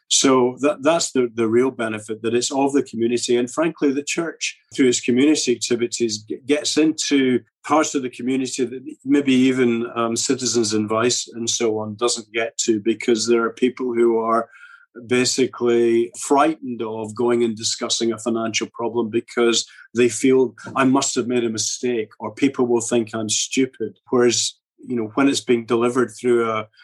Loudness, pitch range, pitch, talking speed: -20 LUFS, 115-130 Hz, 120 Hz, 175 wpm